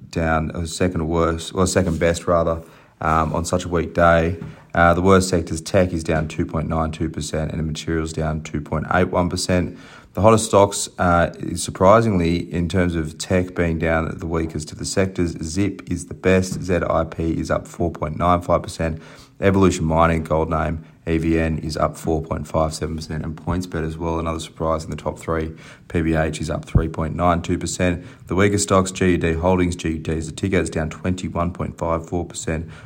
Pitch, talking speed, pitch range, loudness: 85 Hz, 155 wpm, 80-90 Hz, -21 LUFS